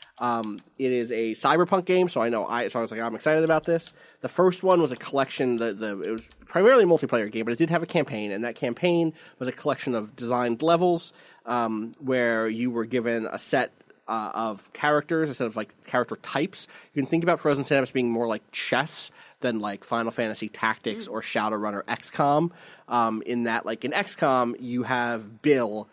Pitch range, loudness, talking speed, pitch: 115-155 Hz, -26 LUFS, 210 wpm, 125 Hz